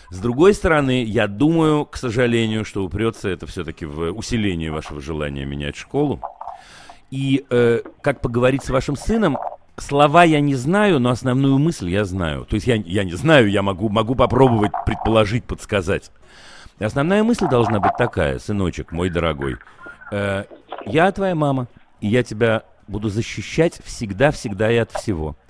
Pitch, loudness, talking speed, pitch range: 115 Hz, -19 LUFS, 155 wpm, 100-135 Hz